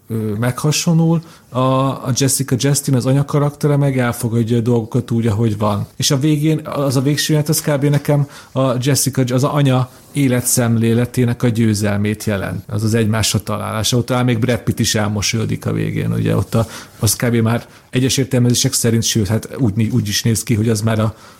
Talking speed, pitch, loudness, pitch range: 180 wpm, 120 Hz, -16 LUFS, 115-140 Hz